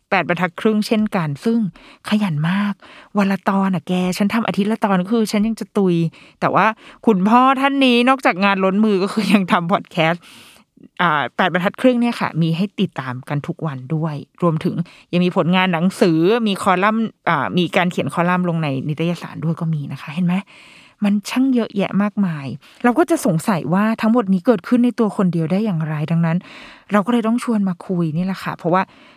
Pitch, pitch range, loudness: 195 Hz, 170-220 Hz, -18 LUFS